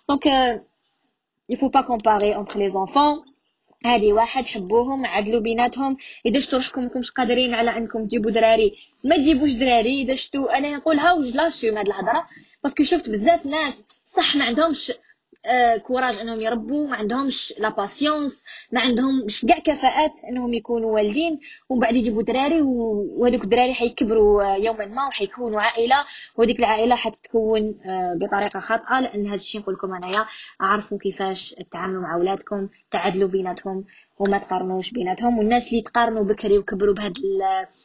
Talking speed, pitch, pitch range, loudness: 145 wpm, 235 Hz, 210-270 Hz, -21 LUFS